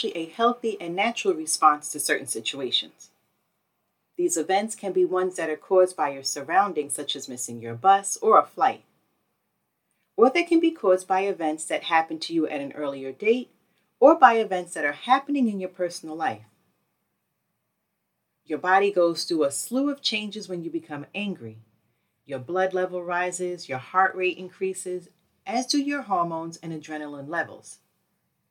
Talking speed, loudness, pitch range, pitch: 165 wpm, -24 LUFS, 150-200 Hz, 180 Hz